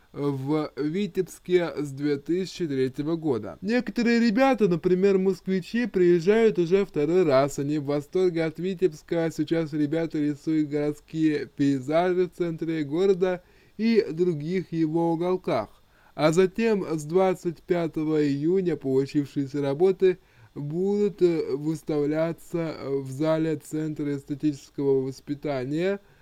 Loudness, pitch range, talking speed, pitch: -25 LUFS, 150-185 Hz, 100 wpm, 165 Hz